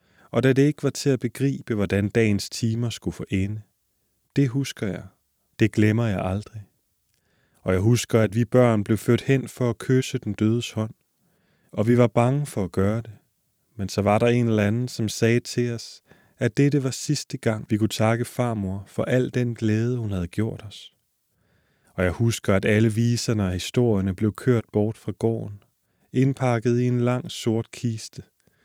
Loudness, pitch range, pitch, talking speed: -23 LUFS, 105-125 Hz, 115 Hz, 190 wpm